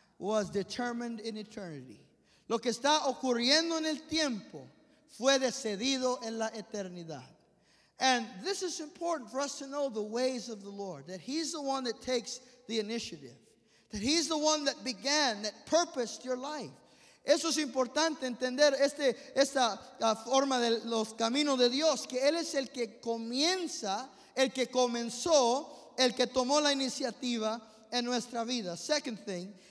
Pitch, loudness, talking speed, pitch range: 250 Hz, -32 LUFS, 160 wpm, 225-280 Hz